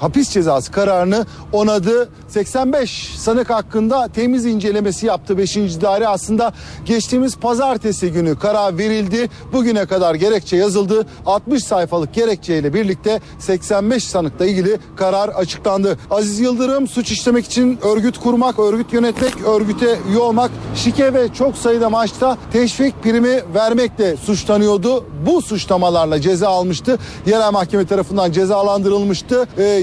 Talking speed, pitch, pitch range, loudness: 125 wpm, 215 Hz, 195-240 Hz, -16 LUFS